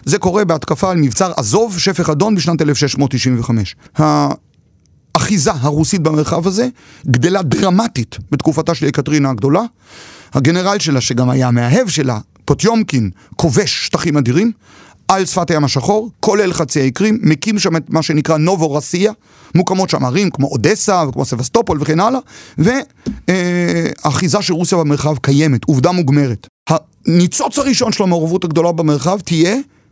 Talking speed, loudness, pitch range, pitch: 135 wpm, -14 LUFS, 145-190 Hz, 160 Hz